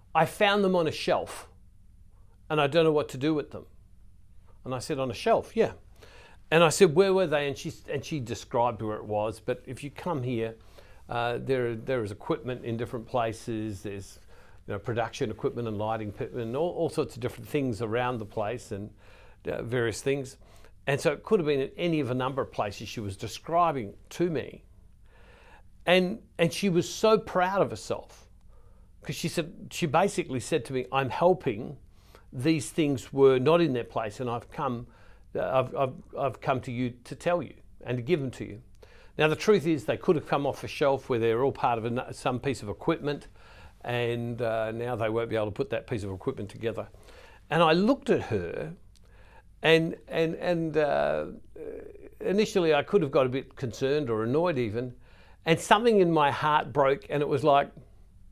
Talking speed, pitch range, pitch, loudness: 200 wpm, 105-155 Hz, 125 Hz, -28 LUFS